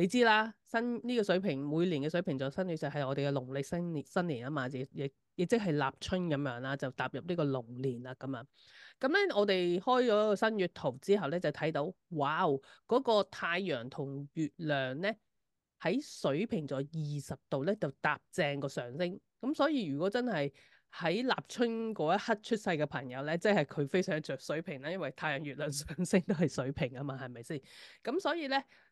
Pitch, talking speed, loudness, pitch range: 160 Hz, 290 characters per minute, -34 LUFS, 140-205 Hz